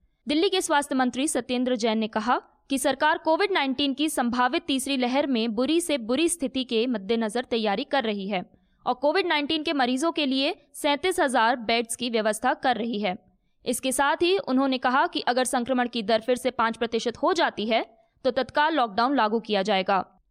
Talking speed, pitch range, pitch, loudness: 190 wpm, 235-290 Hz, 260 Hz, -25 LUFS